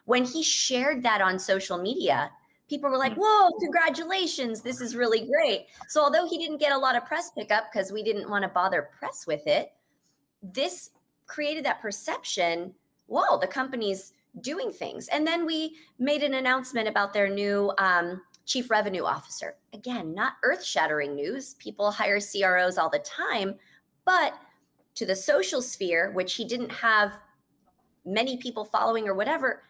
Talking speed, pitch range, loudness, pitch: 165 wpm, 195-285 Hz, -26 LUFS, 225 Hz